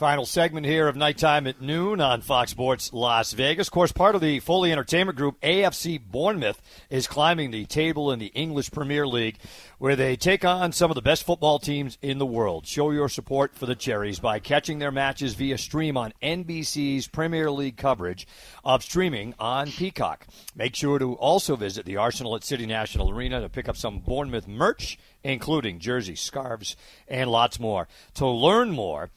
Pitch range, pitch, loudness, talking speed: 120-150 Hz, 135 Hz, -25 LUFS, 185 wpm